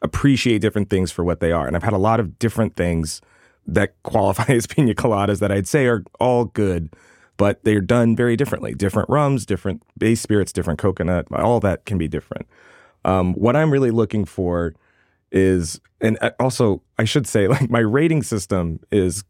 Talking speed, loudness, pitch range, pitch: 185 wpm, -20 LUFS, 95-120 Hz, 105 Hz